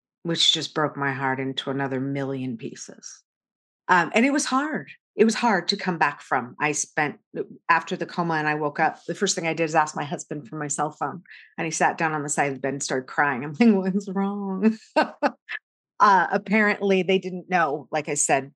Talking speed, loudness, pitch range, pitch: 225 wpm, -23 LUFS, 145-195 Hz, 165 Hz